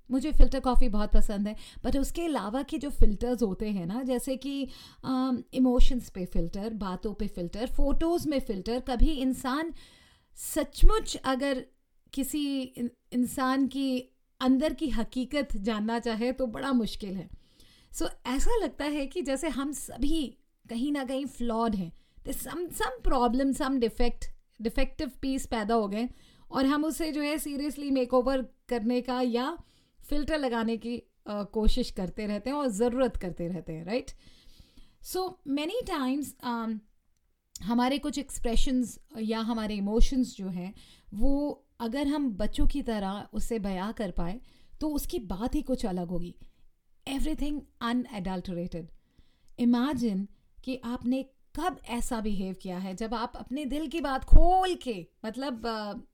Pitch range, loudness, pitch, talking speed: 225-280 Hz, -31 LUFS, 250 Hz, 150 wpm